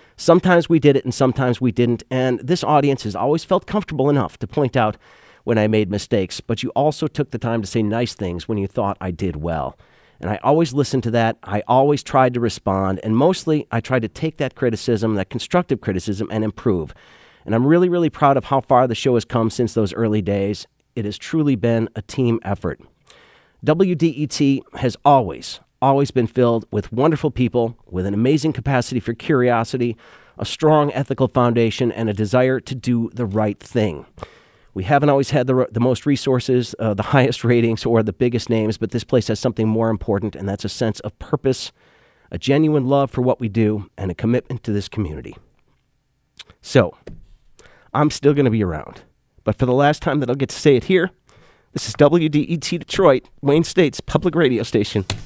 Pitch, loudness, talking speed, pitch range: 120 Hz, -19 LUFS, 200 wpm, 110-140 Hz